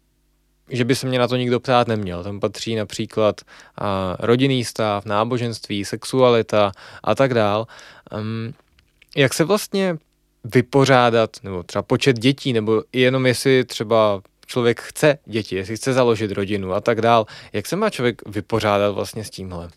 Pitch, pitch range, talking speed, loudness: 115 Hz, 105-130 Hz, 150 wpm, -20 LUFS